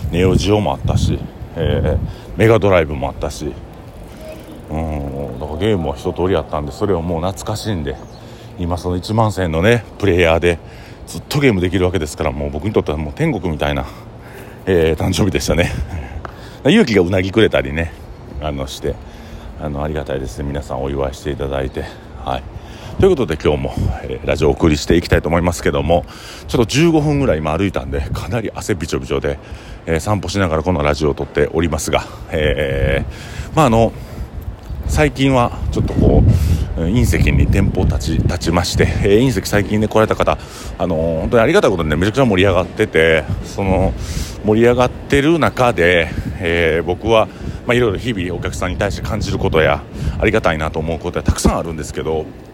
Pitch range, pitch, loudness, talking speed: 80-110 Hz, 90 Hz, -17 LUFS, 400 characters per minute